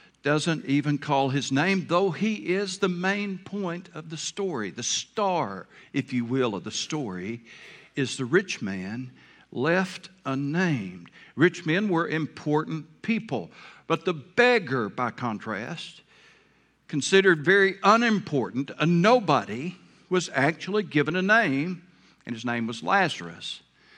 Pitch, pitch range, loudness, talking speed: 165 Hz, 135-190 Hz, -25 LUFS, 135 wpm